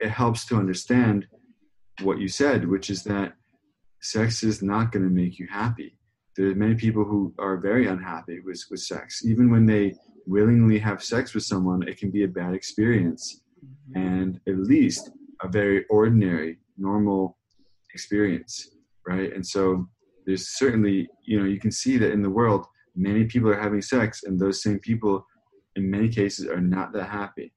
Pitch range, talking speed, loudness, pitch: 95-110 Hz, 175 wpm, -24 LUFS, 100 Hz